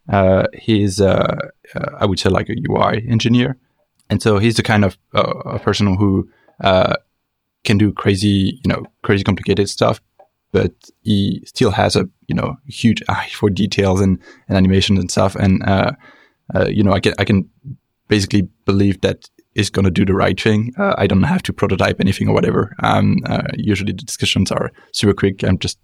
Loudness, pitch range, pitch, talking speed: -17 LUFS, 95-110 Hz, 100 Hz, 195 wpm